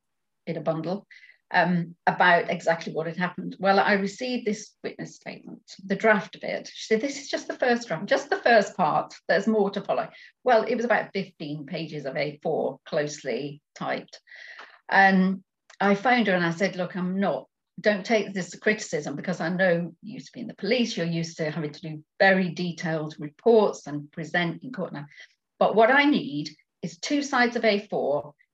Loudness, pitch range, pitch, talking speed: -25 LUFS, 165-220 Hz, 190 Hz, 195 wpm